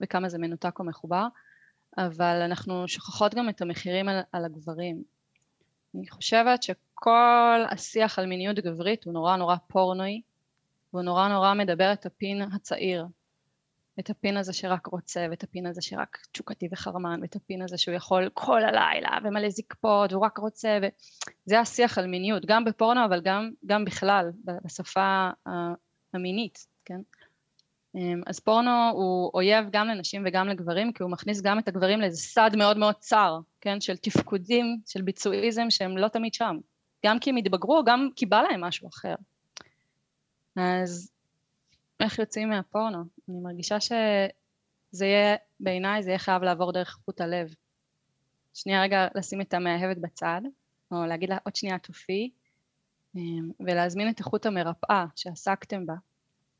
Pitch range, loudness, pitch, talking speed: 180-210 Hz, -27 LUFS, 190 Hz, 150 wpm